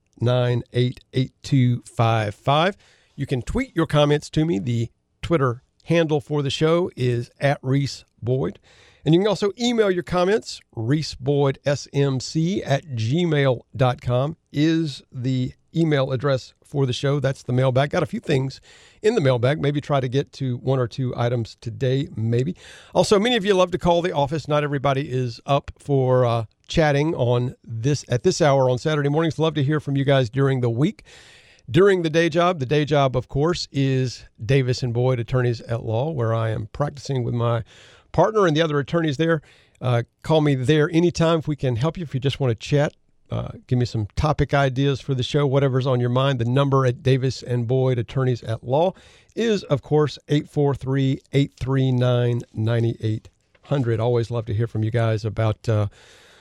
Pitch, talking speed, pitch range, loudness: 135 Hz, 185 wpm, 125-150 Hz, -22 LUFS